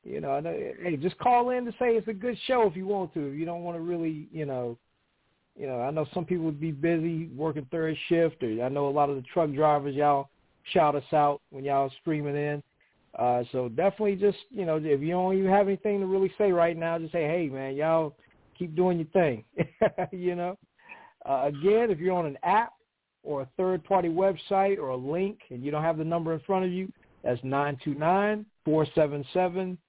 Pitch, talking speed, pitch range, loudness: 170 Hz, 220 wpm, 145-190 Hz, -28 LUFS